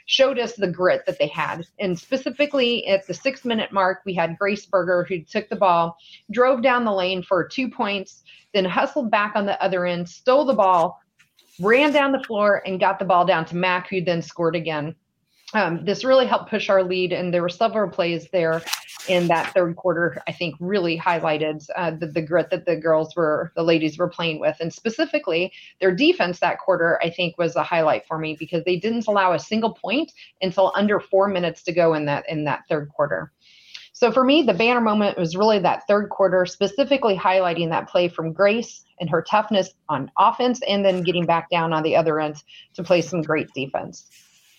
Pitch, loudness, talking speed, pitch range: 185 Hz, -21 LUFS, 210 wpm, 170-215 Hz